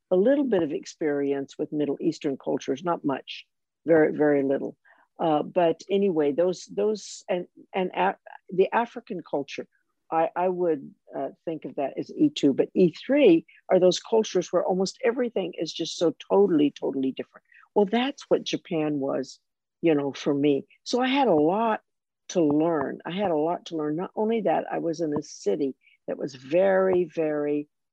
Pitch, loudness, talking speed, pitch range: 175 Hz, -25 LUFS, 175 wpm, 150-200 Hz